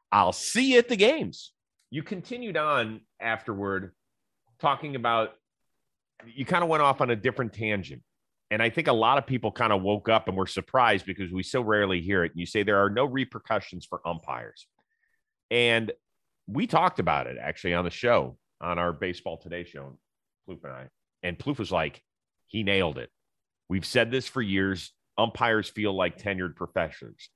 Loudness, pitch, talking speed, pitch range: -27 LUFS, 105 Hz, 185 wpm, 95-130 Hz